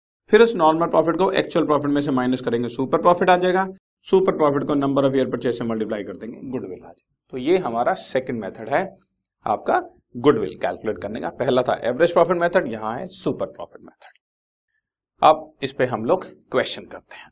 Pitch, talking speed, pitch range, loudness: 155 Hz, 200 wpm, 130-185 Hz, -21 LUFS